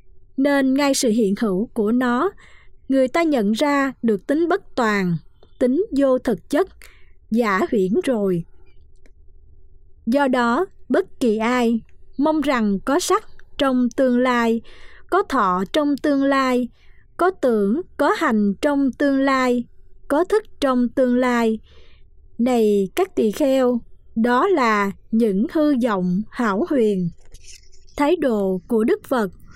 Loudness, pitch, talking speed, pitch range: -20 LUFS, 250 Hz, 135 wpm, 215-285 Hz